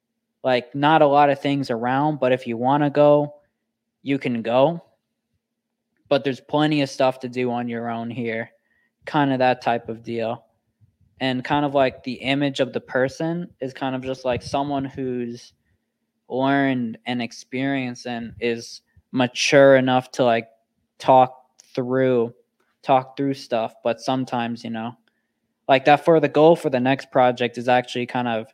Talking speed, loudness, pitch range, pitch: 170 wpm, -21 LUFS, 120-140 Hz, 130 Hz